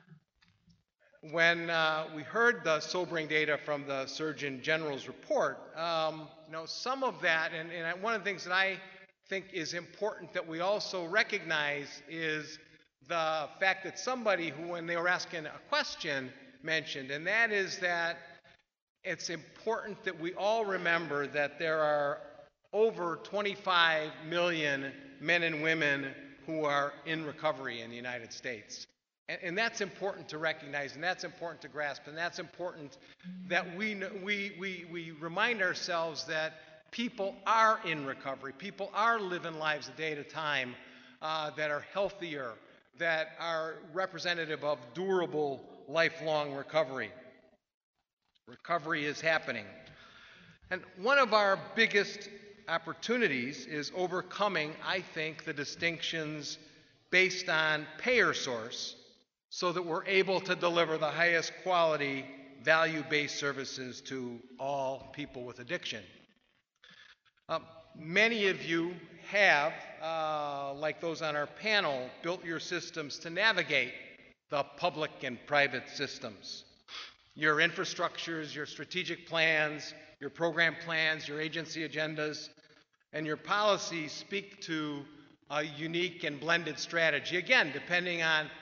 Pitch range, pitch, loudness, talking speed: 150-180 Hz, 160 Hz, -32 LUFS, 135 wpm